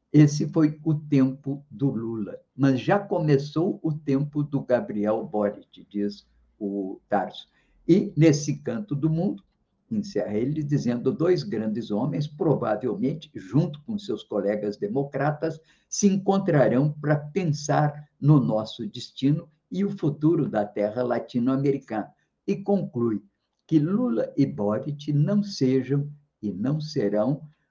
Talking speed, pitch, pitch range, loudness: 125 wpm, 145 Hz, 120-160 Hz, -25 LUFS